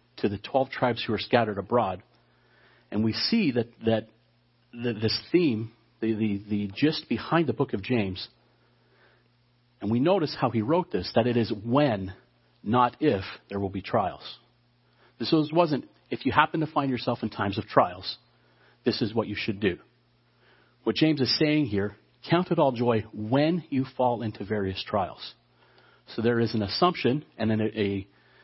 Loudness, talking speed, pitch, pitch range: -27 LUFS, 180 wpm, 120 Hz, 110-135 Hz